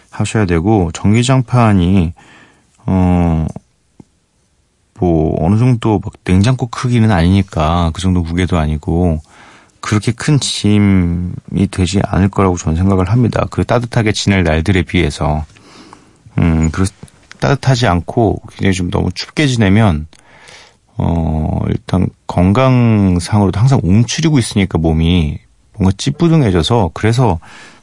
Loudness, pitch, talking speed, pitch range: -13 LUFS, 95 Hz, 260 characters per minute, 85-115 Hz